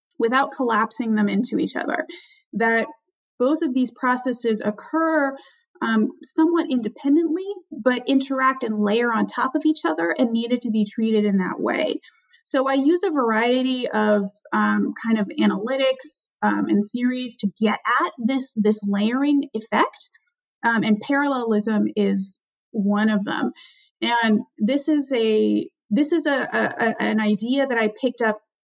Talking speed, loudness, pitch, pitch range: 155 wpm, -21 LUFS, 245 Hz, 215-285 Hz